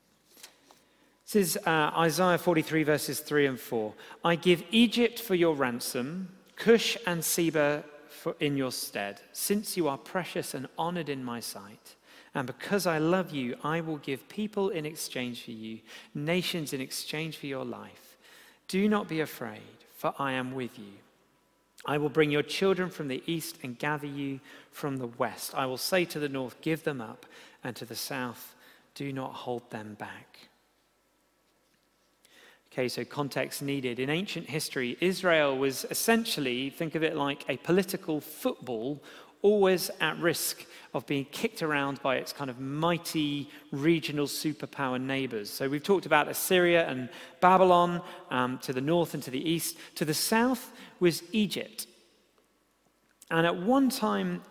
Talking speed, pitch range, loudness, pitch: 160 wpm, 135-175 Hz, -29 LUFS, 150 Hz